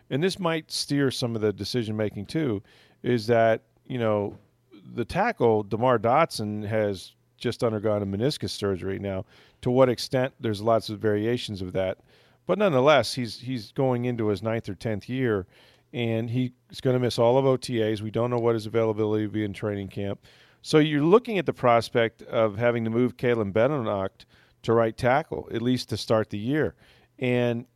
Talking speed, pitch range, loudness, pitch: 185 wpm, 105-125 Hz, -26 LUFS, 115 Hz